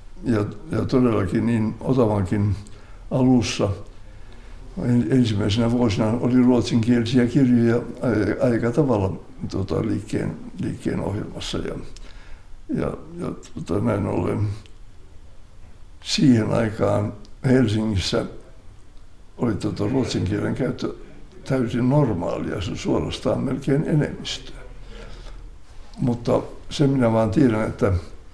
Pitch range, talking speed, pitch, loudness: 100-120 Hz, 90 wpm, 110 Hz, -22 LUFS